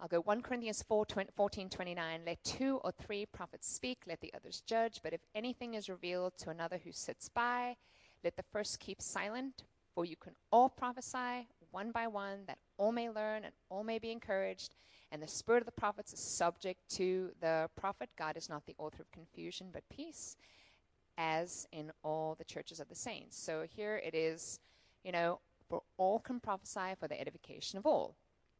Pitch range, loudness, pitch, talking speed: 165-220 Hz, -40 LUFS, 185 Hz, 195 wpm